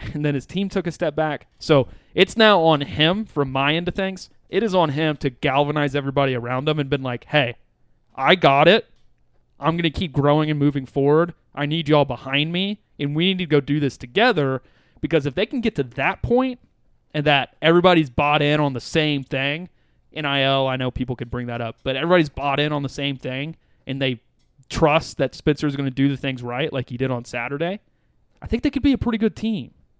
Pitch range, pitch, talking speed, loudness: 135-165 Hz, 145 Hz, 230 wpm, -21 LUFS